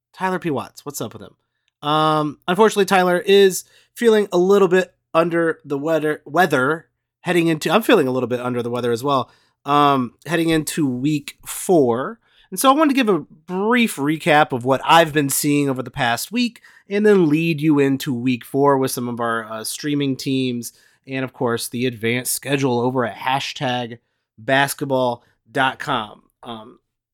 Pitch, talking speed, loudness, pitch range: 145 Hz, 175 wpm, -19 LUFS, 125-170 Hz